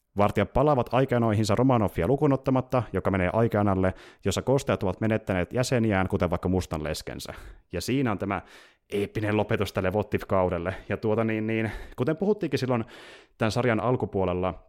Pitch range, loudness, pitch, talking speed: 95-120 Hz, -26 LUFS, 105 Hz, 145 wpm